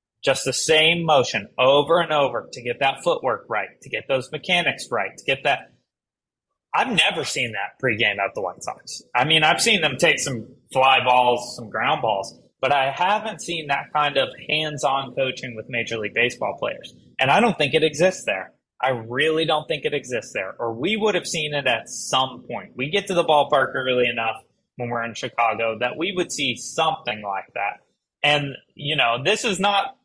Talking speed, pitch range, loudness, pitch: 205 wpm, 125-160 Hz, -21 LUFS, 140 Hz